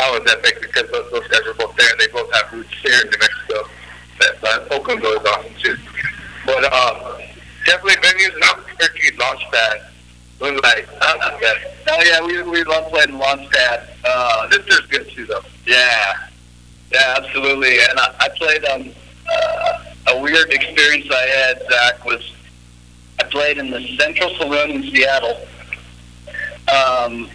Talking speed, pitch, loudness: 155 wpm, 135 Hz, -15 LUFS